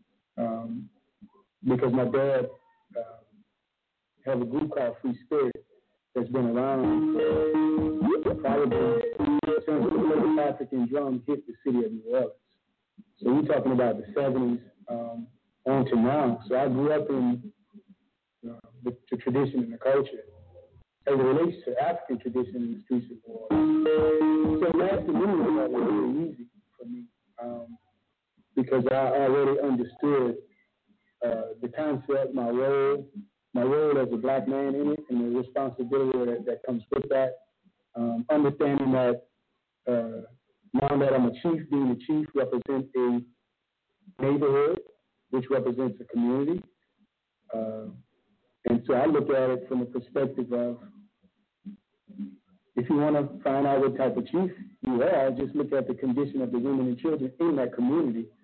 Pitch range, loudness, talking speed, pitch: 125-190 Hz, -27 LUFS, 160 wpm, 135 Hz